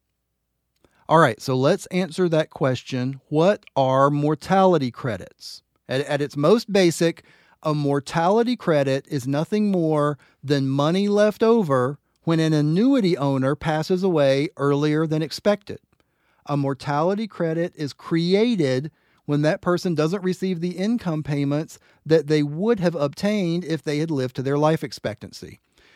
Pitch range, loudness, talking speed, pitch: 140-180 Hz, -22 LUFS, 140 wpm, 155 Hz